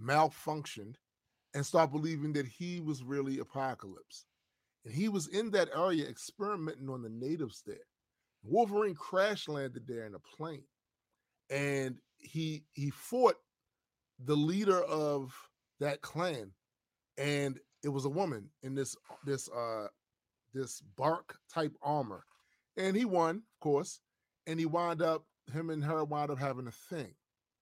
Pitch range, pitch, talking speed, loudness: 130-165 Hz, 145 Hz, 145 wpm, -36 LUFS